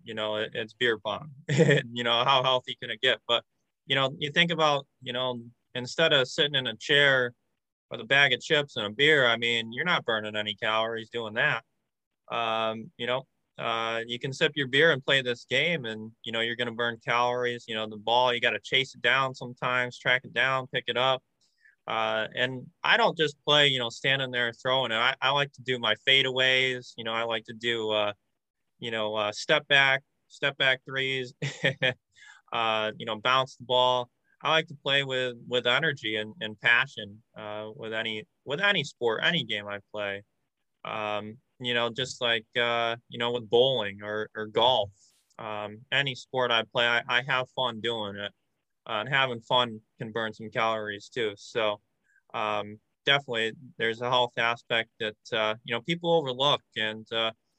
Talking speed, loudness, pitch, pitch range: 195 wpm, -26 LUFS, 120 Hz, 110-130 Hz